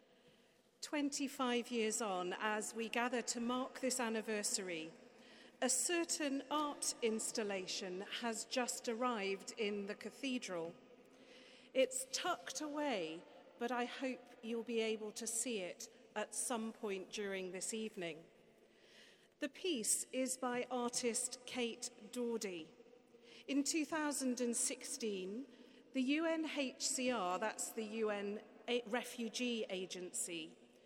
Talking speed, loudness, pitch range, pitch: 105 wpm, -41 LUFS, 220-255 Hz, 240 Hz